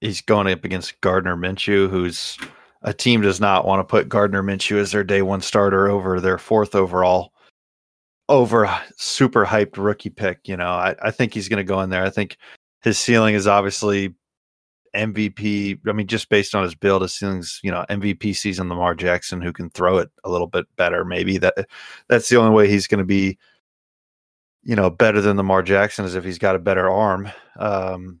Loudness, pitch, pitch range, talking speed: -19 LUFS, 100 Hz, 95-105 Hz, 200 wpm